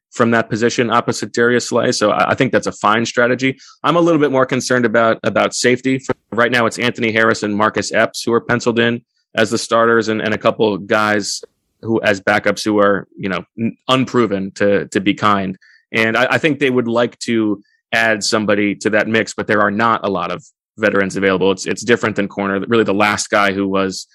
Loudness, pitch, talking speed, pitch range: -16 LUFS, 115 Hz, 220 wpm, 105-120 Hz